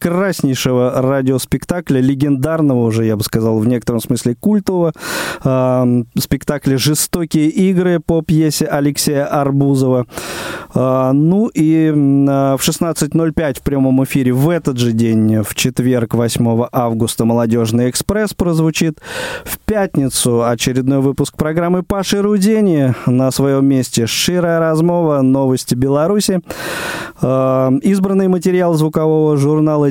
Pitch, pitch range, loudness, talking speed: 140 Hz, 130-170 Hz, -14 LUFS, 115 wpm